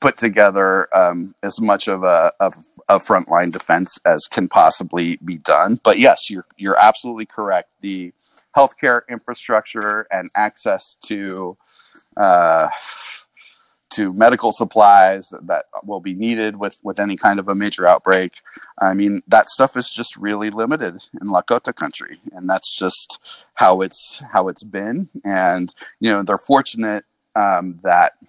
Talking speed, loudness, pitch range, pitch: 150 wpm, -16 LUFS, 95-110 Hz, 100 Hz